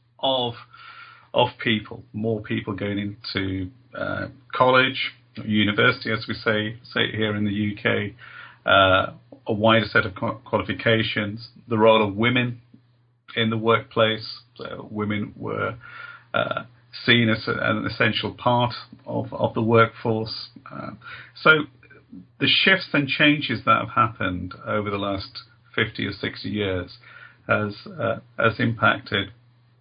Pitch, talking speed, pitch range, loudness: 115 Hz, 135 wpm, 105-125 Hz, -22 LUFS